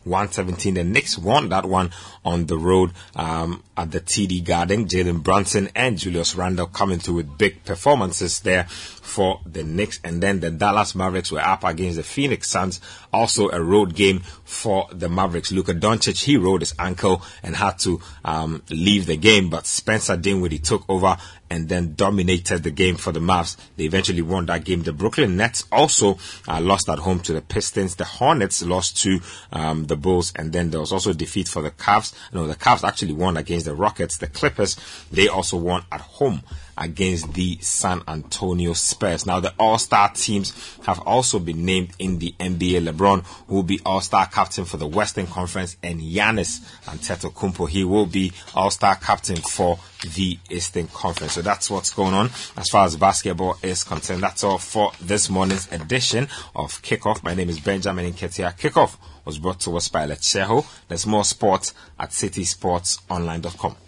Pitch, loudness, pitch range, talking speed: 90 Hz, -21 LUFS, 85-100 Hz, 185 wpm